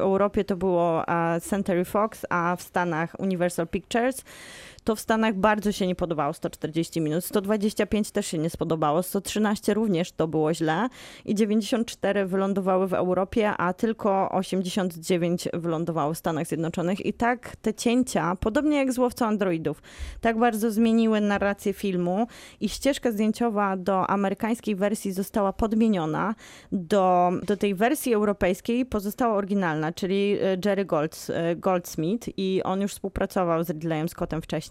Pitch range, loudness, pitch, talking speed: 175-215 Hz, -25 LUFS, 195 Hz, 145 wpm